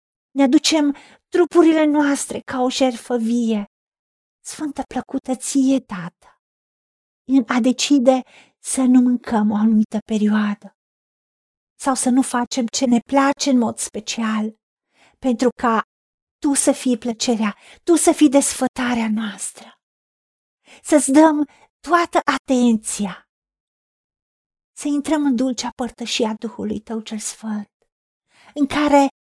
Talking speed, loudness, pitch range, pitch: 115 wpm, -19 LUFS, 225-280 Hz, 255 Hz